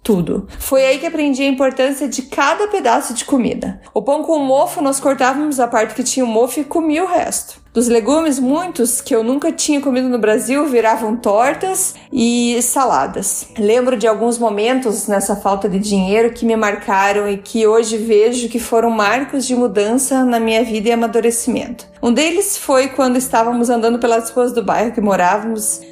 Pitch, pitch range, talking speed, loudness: 240 Hz, 225-275 Hz, 185 wpm, -15 LUFS